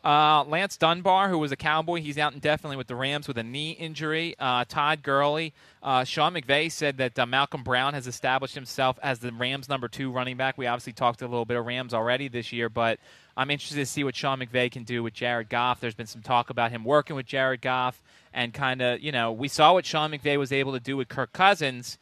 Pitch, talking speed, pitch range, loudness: 135 Hz, 245 wpm, 125-150 Hz, -26 LUFS